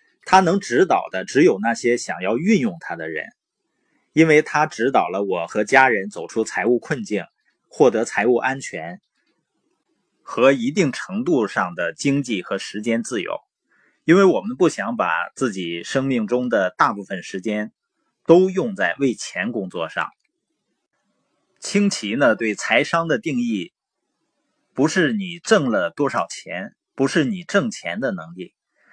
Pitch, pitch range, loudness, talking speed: 150 Hz, 120-200 Hz, -20 LUFS, 215 characters per minute